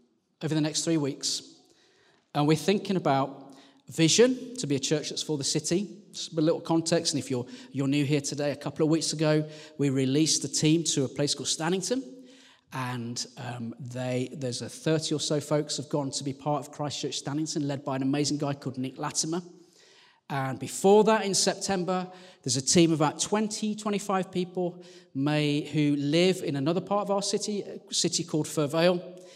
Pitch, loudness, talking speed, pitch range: 155 Hz, -27 LUFS, 195 wpm, 140-180 Hz